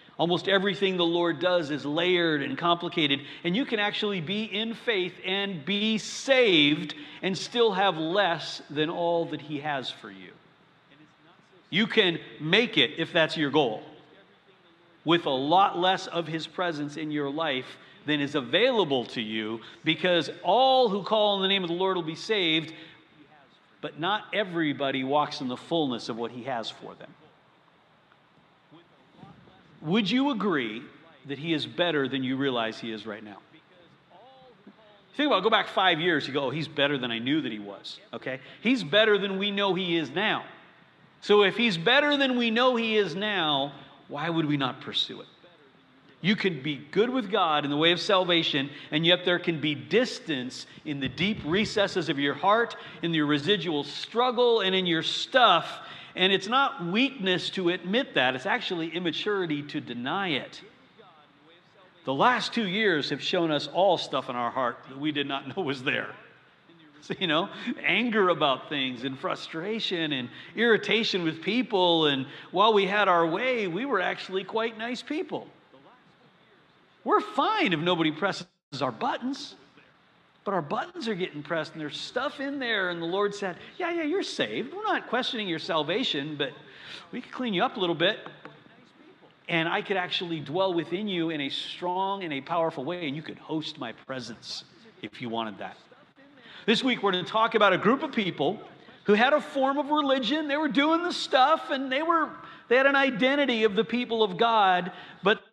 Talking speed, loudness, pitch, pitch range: 185 wpm, -26 LUFS, 180 Hz, 155-215 Hz